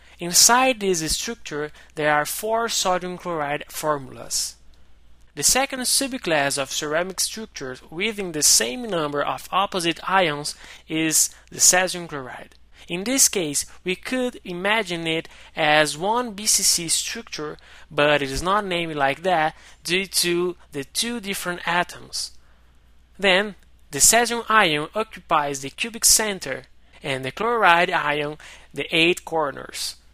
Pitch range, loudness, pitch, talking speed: 145-195 Hz, -21 LUFS, 170 Hz, 130 wpm